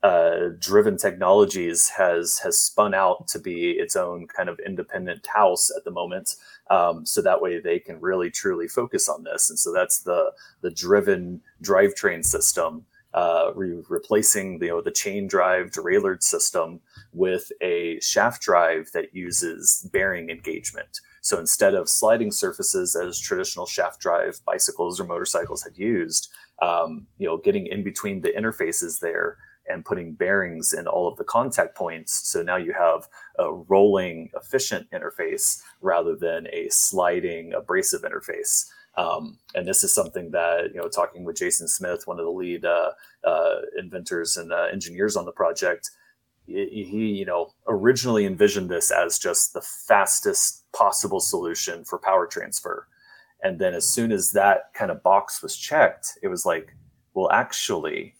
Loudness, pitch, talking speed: -23 LUFS, 390 Hz, 160 wpm